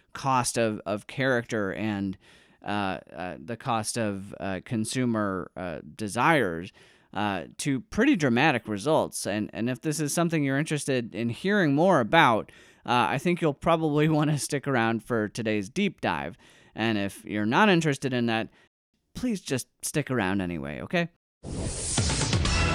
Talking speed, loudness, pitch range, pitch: 150 wpm, -27 LUFS, 105-150 Hz, 120 Hz